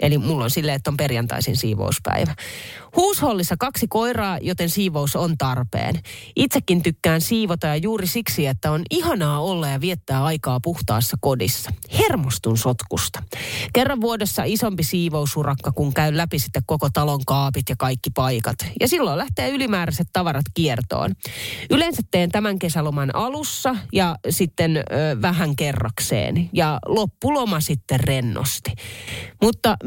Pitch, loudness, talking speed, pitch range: 150 Hz, -21 LUFS, 135 wpm, 130-180 Hz